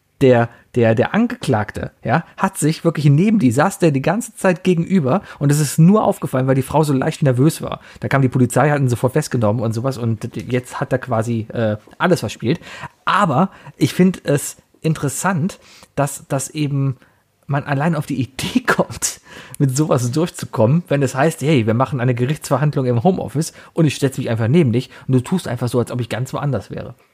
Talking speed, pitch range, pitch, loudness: 200 wpm, 125-160 Hz, 140 Hz, -18 LUFS